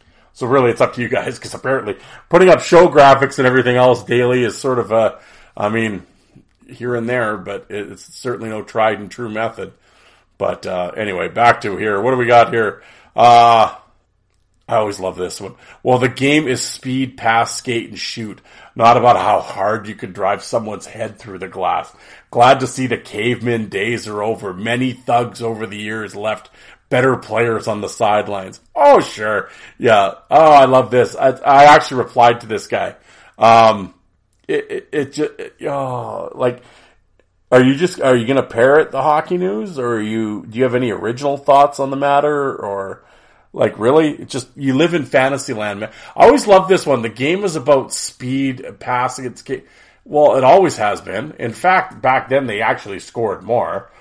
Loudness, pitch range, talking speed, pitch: -15 LUFS, 110-135 Hz, 190 wpm, 125 Hz